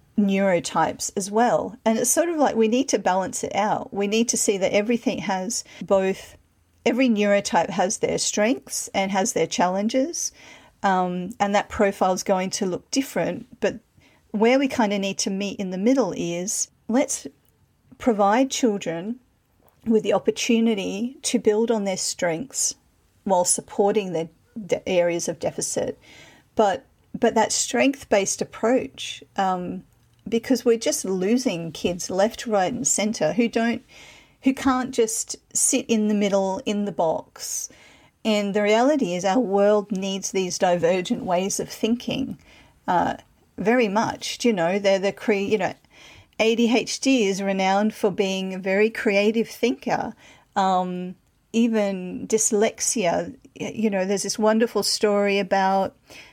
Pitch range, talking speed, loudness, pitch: 195-235 Hz, 150 wpm, -23 LUFS, 210 Hz